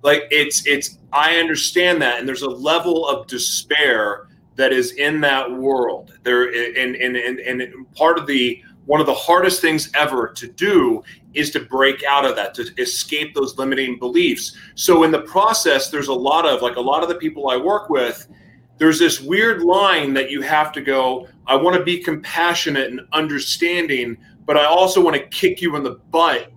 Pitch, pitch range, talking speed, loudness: 150 Hz, 135-175 Hz, 190 wpm, -17 LUFS